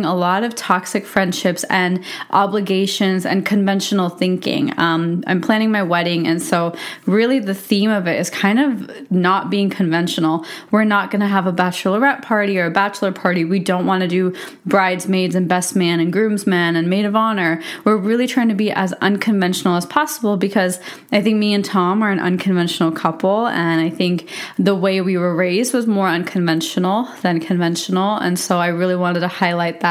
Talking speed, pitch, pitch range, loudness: 190 wpm, 190 Hz, 180-205 Hz, -17 LUFS